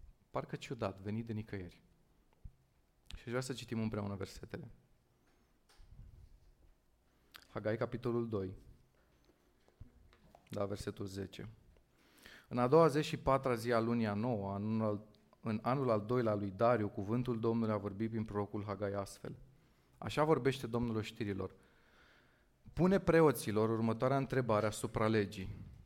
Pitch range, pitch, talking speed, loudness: 100-120 Hz, 110 Hz, 125 wpm, -36 LUFS